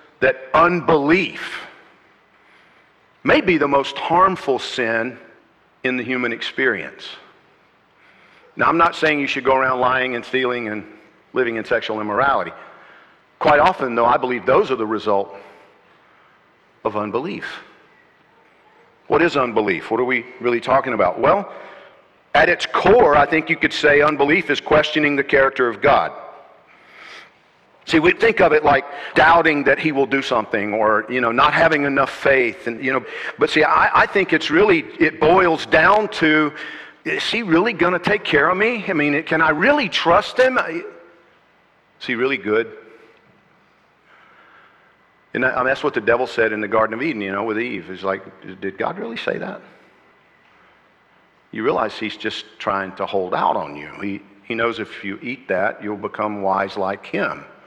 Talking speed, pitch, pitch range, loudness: 170 wpm, 140 Hz, 115-160 Hz, -18 LUFS